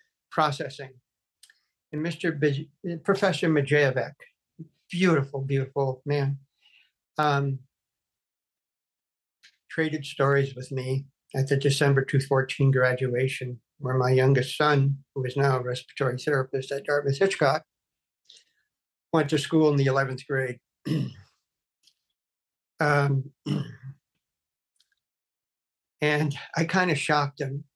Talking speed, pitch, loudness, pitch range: 100 wpm, 140 Hz, -26 LUFS, 135-150 Hz